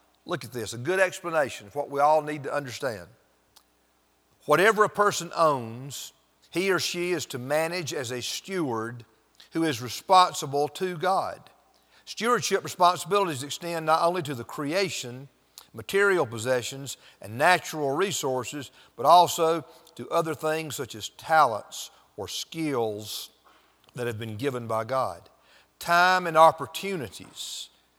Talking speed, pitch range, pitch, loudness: 135 wpm, 125-175 Hz, 150 Hz, -26 LUFS